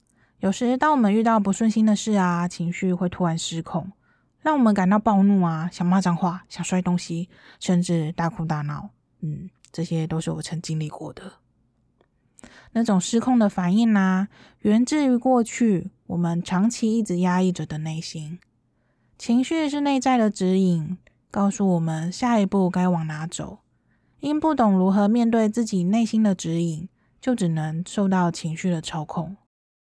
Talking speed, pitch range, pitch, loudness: 245 characters per minute, 165-220 Hz, 185 Hz, -23 LUFS